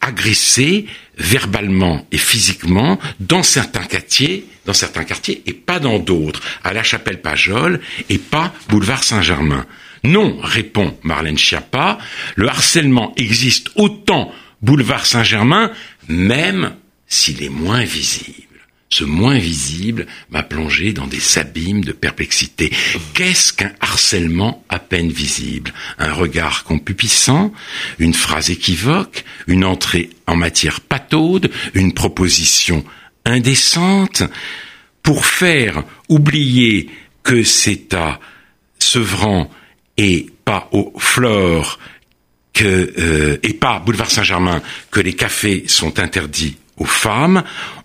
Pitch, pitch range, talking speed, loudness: 100 Hz, 85-125 Hz, 115 wpm, -14 LUFS